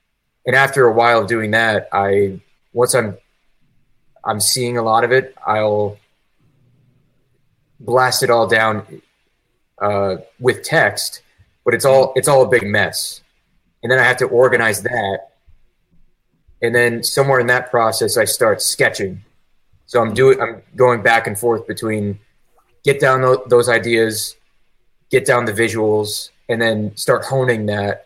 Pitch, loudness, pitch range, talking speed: 115 Hz, -16 LUFS, 105-130 Hz, 150 wpm